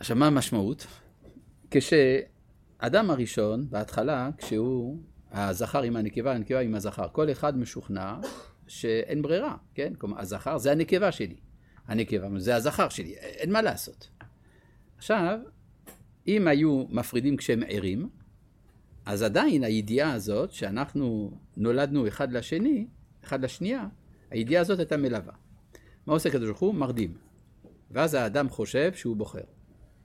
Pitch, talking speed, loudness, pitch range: 125 Hz, 120 wpm, -28 LUFS, 110-150 Hz